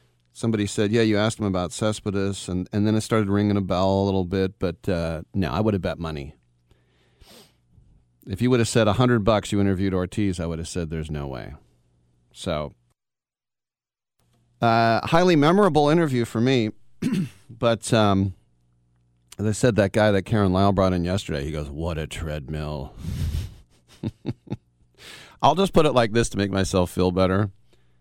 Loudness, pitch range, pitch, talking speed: -23 LUFS, 80-110 Hz, 95 Hz, 170 wpm